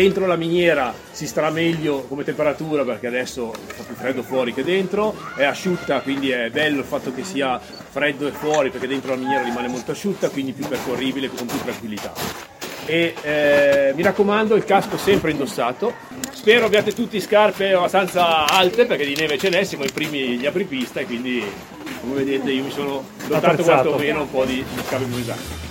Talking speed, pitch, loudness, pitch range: 185 wpm, 150 Hz, -20 LUFS, 130-185 Hz